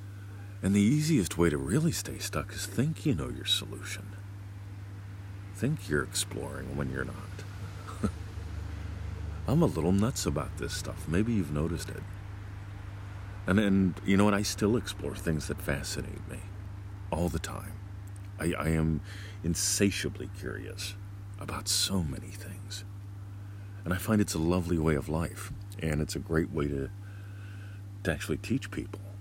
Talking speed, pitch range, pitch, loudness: 150 wpm, 90-100 Hz, 100 Hz, -31 LUFS